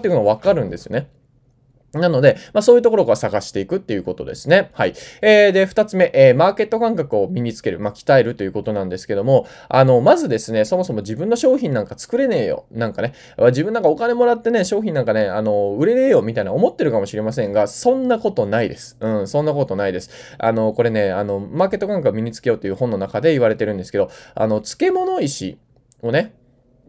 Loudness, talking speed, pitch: -18 LUFS, 475 characters per minute, 130 Hz